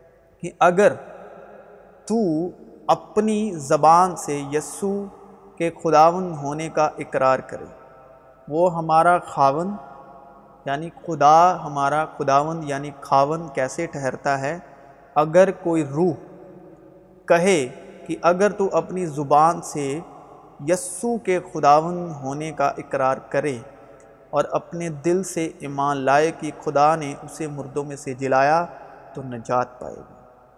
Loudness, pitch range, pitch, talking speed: -21 LUFS, 140-175 Hz, 155 Hz, 120 wpm